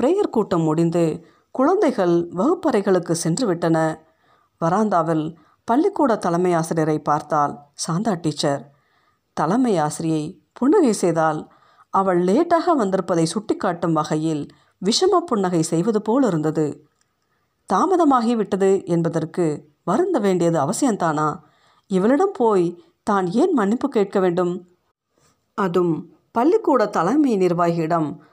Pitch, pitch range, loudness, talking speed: 180 Hz, 160-225 Hz, -20 LUFS, 95 wpm